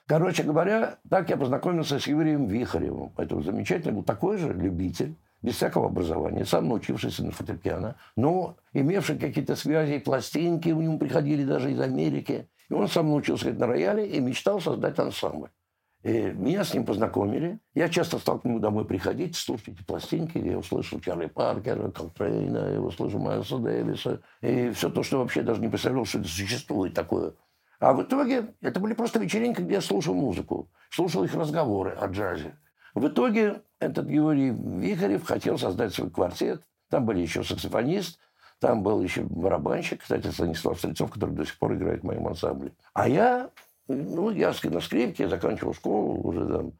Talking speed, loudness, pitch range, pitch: 175 wpm, -27 LUFS, 120-180 Hz, 150 Hz